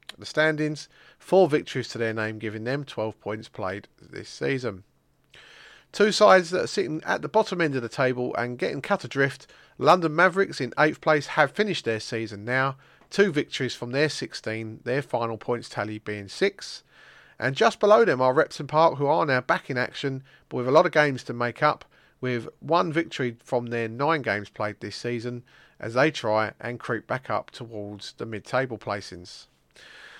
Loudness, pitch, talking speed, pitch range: -25 LUFS, 130 Hz, 190 wpm, 115-155 Hz